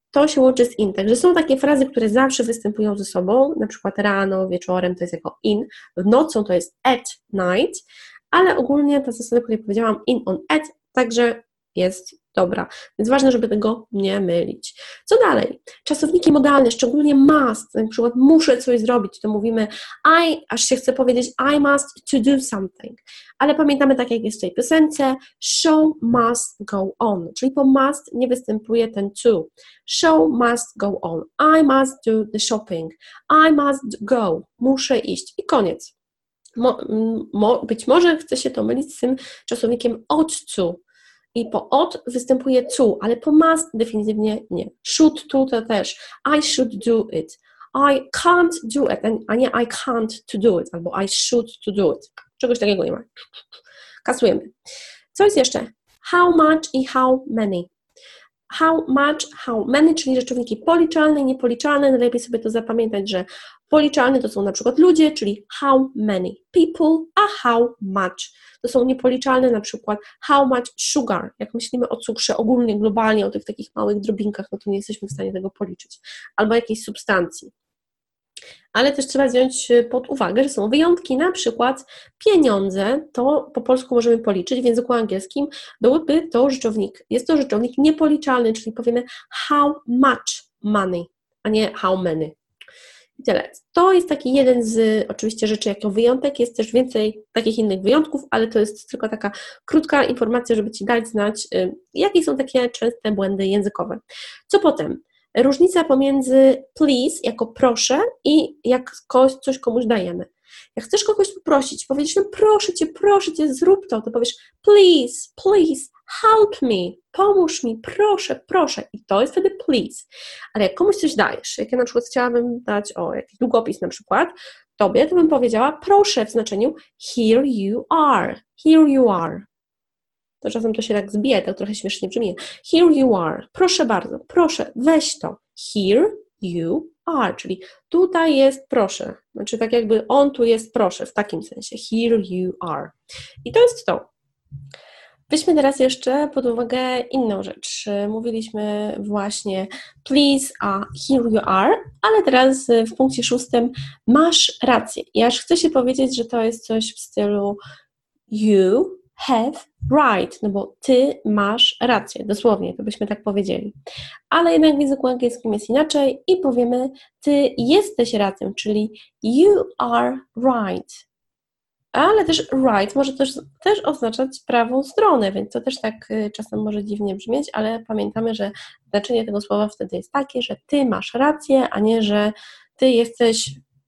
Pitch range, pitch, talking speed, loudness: 215-290 Hz, 245 Hz, 160 wpm, -19 LUFS